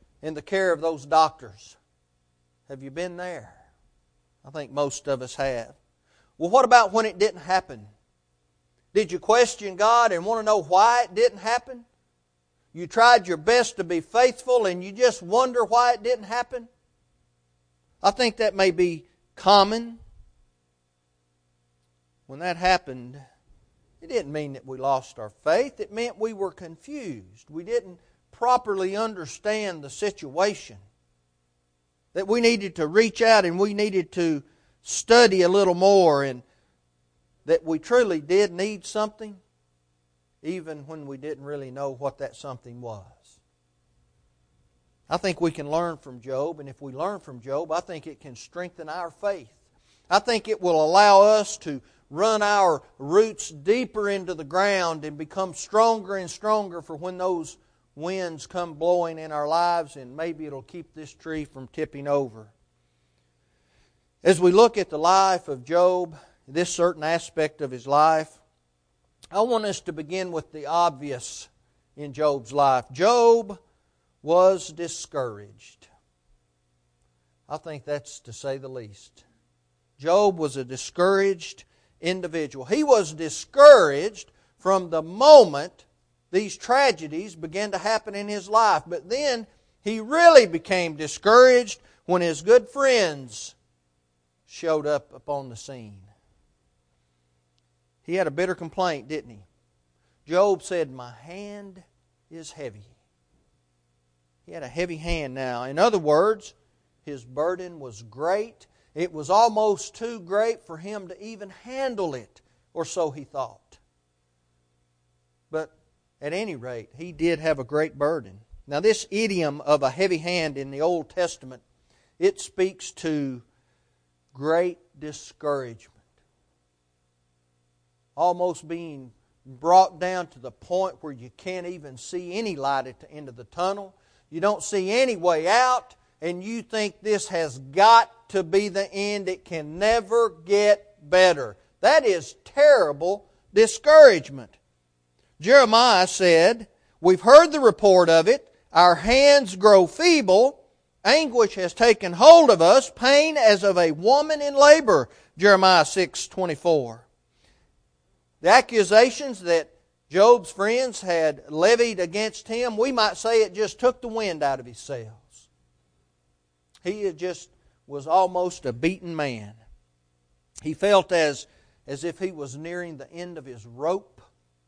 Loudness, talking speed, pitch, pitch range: -21 LUFS, 140 wpm, 165 Hz, 120-200 Hz